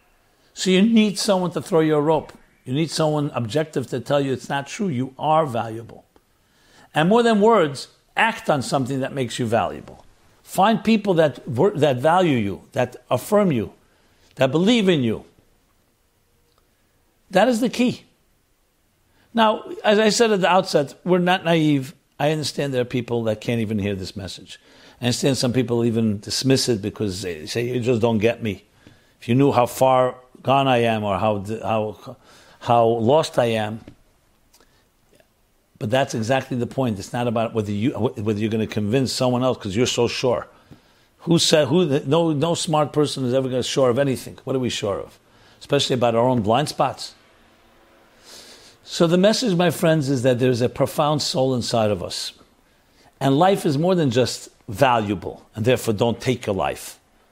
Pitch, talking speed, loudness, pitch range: 130 Hz, 185 wpm, -20 LUFS, 115-160 Hz